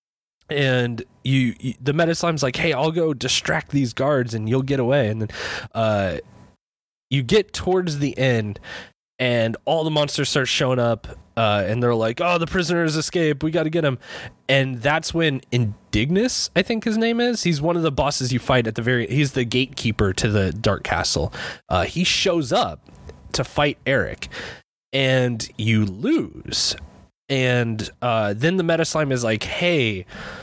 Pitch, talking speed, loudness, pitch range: 130 Hz, 175 wpm, -21 LUFS, 115-160 Hz